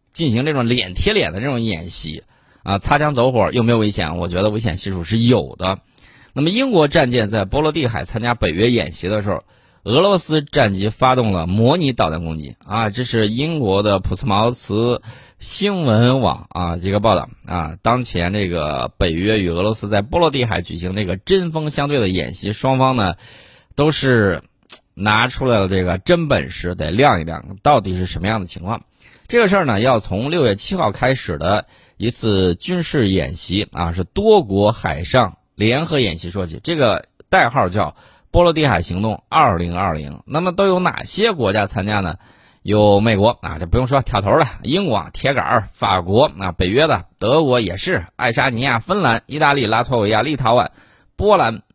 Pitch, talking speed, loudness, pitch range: 110 Hz, 275 characters per minute, -17 LUFS, 95-130 Hz